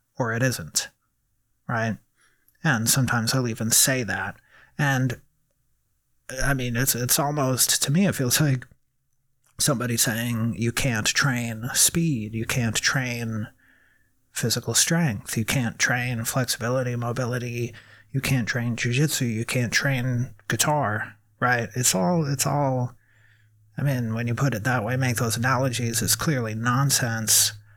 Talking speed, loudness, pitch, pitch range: 140 wpm, -23 LUFS, 125 Hz, 115-135 Hz